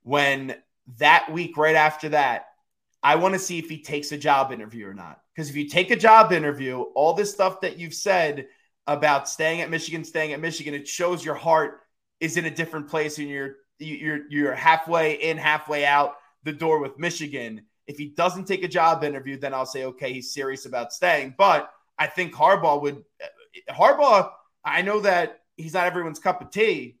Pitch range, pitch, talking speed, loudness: 145-170 Hz, 155 Hz, 200 wpm, -22 LUFS